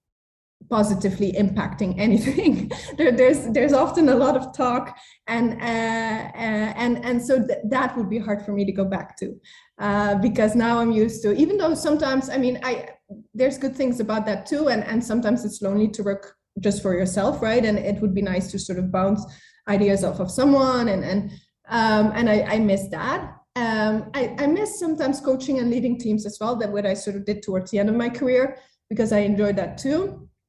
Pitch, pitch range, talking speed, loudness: 225 Hz, 205-255 Hz, 210 wpm, -22 LUFS